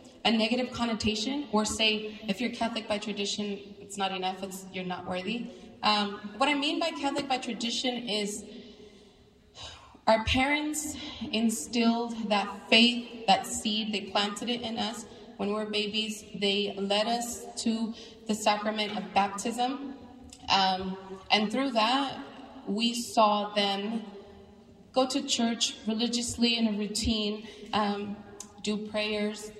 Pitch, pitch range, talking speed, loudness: 215 Hz, 205-235 Hz, 135 wpm, -29 LUFS